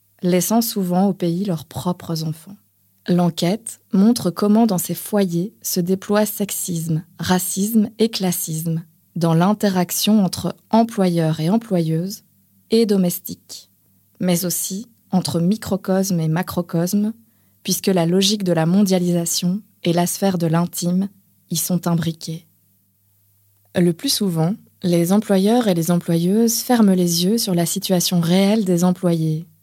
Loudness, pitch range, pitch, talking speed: -19 LUFS, 165-195 Hz, 180 Hz, 130 wpm